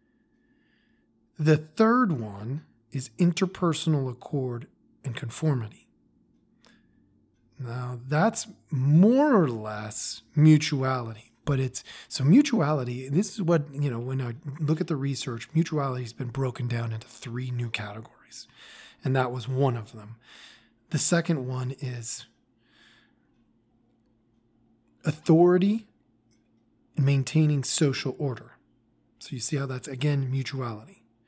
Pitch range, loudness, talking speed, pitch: 120-155 Hz, -26 LUFS, 115 wpm, 130 Hz